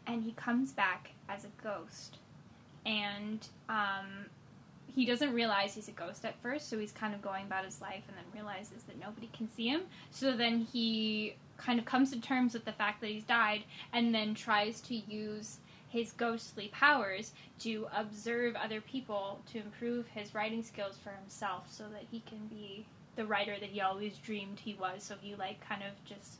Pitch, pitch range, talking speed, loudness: 215 Hz, 200-230 Hz, 195 wpm, -37 LUFS